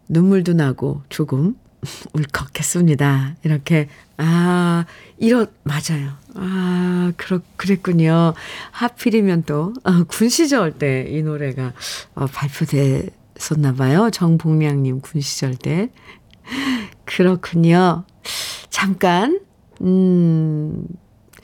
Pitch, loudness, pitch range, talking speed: 165 Hz, -18 LUFS, 145-185 Hz, 185 characters per minute